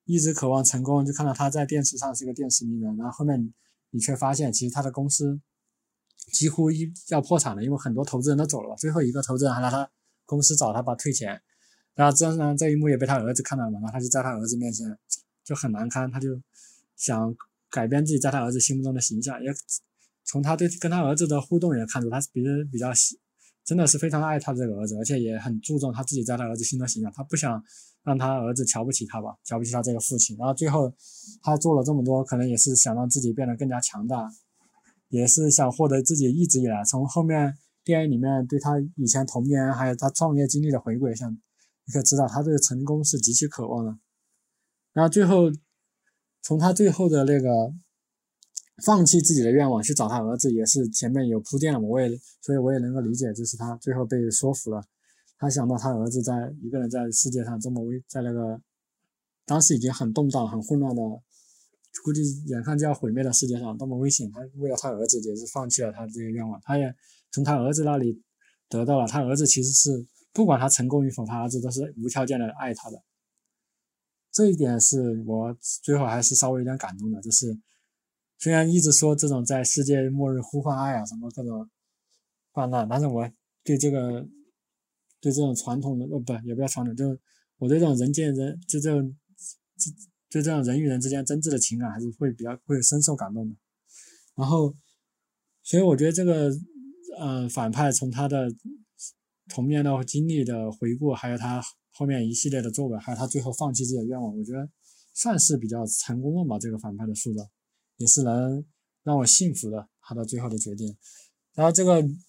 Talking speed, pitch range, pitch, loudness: 315 characters per minute, 120-145 Hz, 135 Hz, -24 LUFS